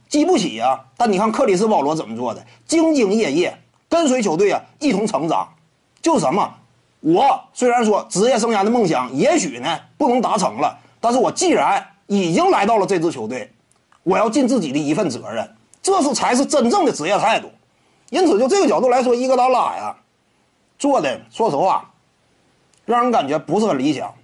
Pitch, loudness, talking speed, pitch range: 275 Hz, -18 LUFS, 285 characters per minute, 245-325 Hz